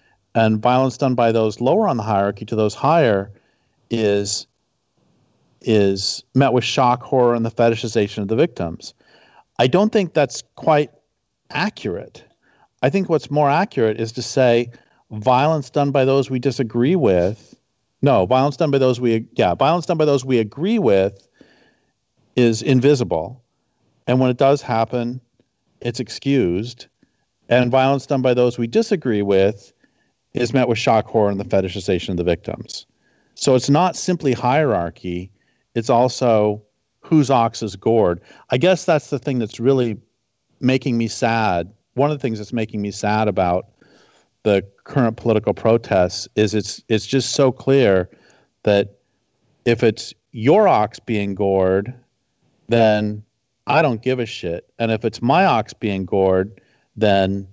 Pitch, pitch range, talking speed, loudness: 120 Hz, 105-130 Hz, 155 wpm, -19 LUFS